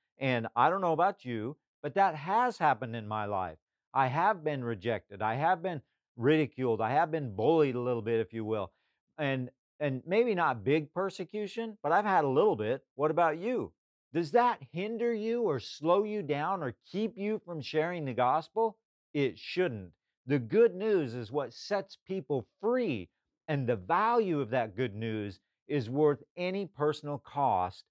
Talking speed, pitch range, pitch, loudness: 180 wpm, 125-195 Hz, 150 Hz, -31 LUFS